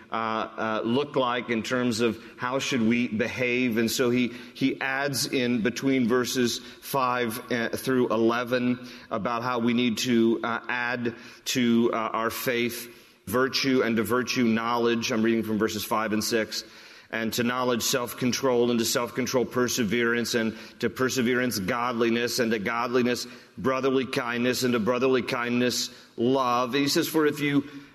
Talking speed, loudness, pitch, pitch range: 155 wpm, -26 LUFS, 120 Hz, 115-125 Hz